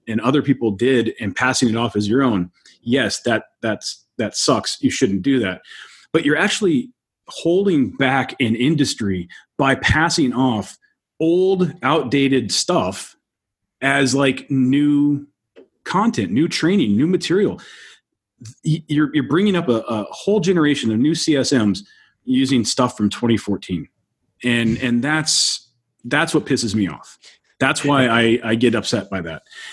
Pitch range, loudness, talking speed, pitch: 115-150 Hz, -18 LUFS, 145 wpm, 130 Hz